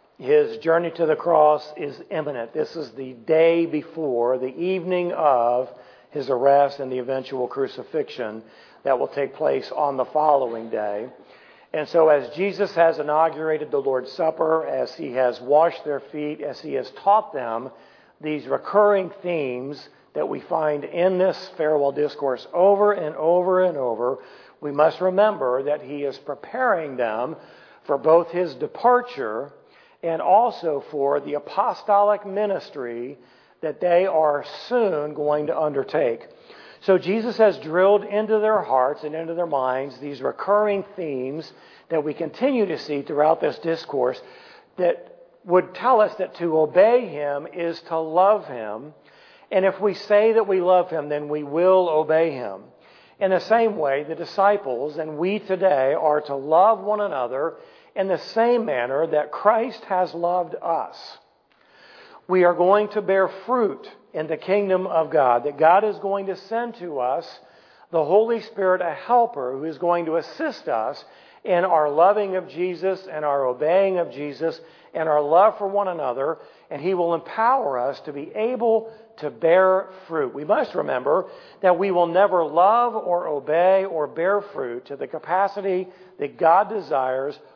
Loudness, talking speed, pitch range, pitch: -22 LUFS, 160 wpm, 150-200 Hz, 170 Hz